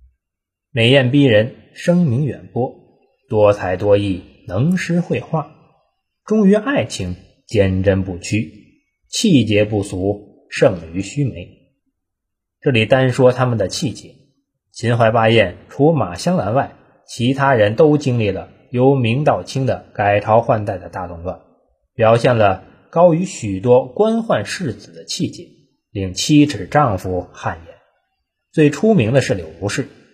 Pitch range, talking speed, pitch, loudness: 95-140 Hz, 195 characters per minute, 115 Hz, -17 LUFS